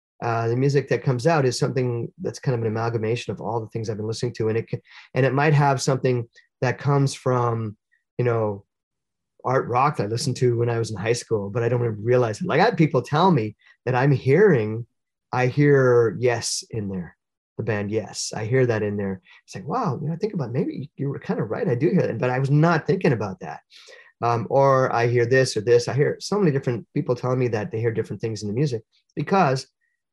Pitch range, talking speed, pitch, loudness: 115-145 Hz, 245 wpm, 125 Hz, -22 LUFS